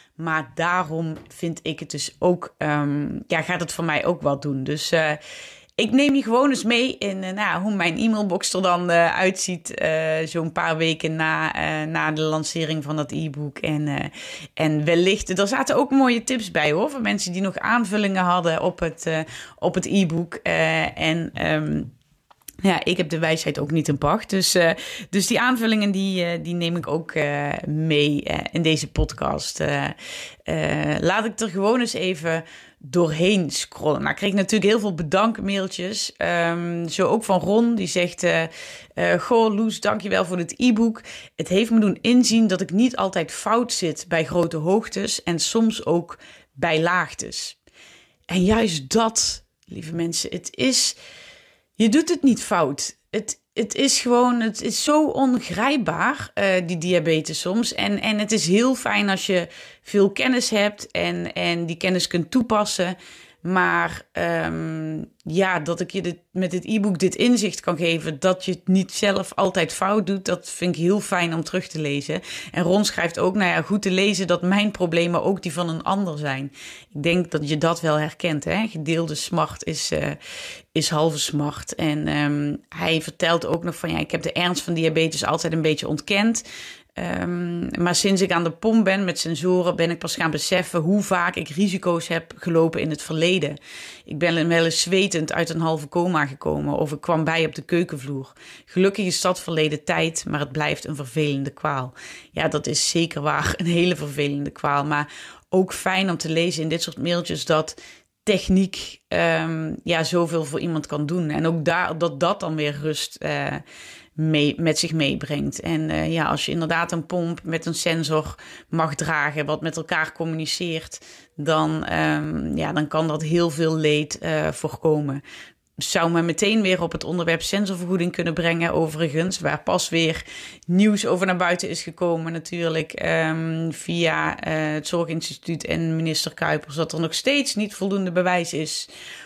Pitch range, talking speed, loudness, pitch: 155-190 Hz, 185 wpm, -22 LUFS, 170 Hz